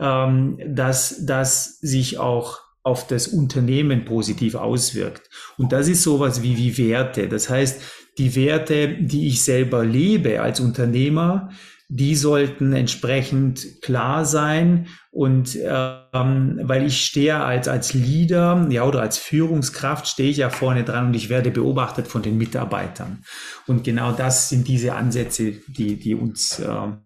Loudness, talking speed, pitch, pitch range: -20 LUFS, 145 wpm, 130 Hz, 125-145 Hz